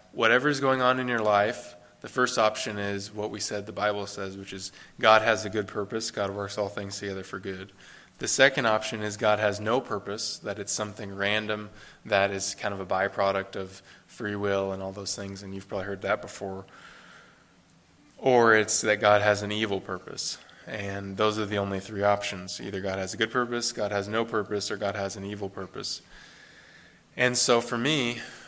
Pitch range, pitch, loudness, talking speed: 100-110 Hz, 105 Hz, -27 LUFS, 205 wpm